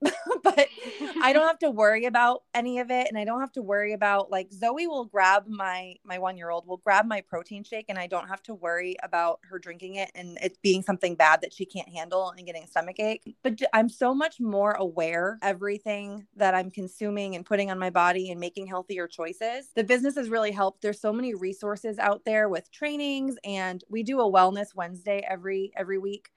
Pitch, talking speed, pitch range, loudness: 200 Hz, 220 wpm, 185-225 Hz, -27 LUFS